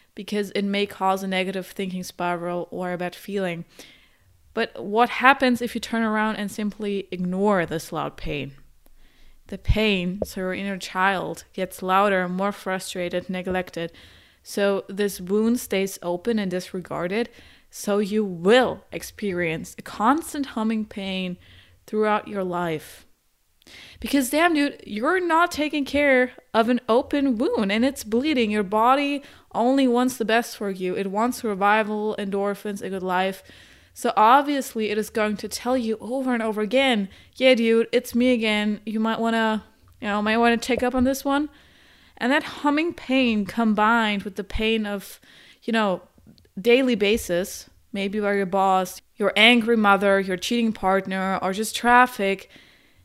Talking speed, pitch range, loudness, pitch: 160 wpm, 190-235 Hz, -23 LUFS, 210 Hz